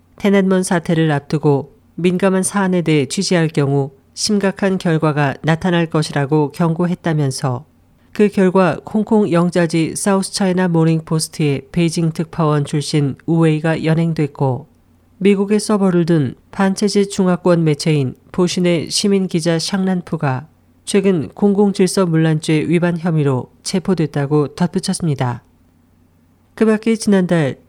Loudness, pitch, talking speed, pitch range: -16 LUFS, 170 Hz, 295 characters per minute, 150-190 Hz